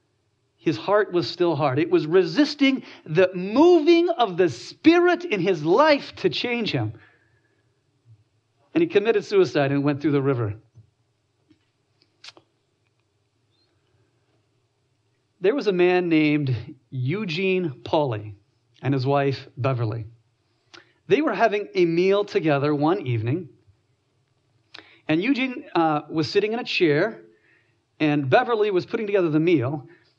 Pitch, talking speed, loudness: 145 Hz, 125 wpm, -22 LUFS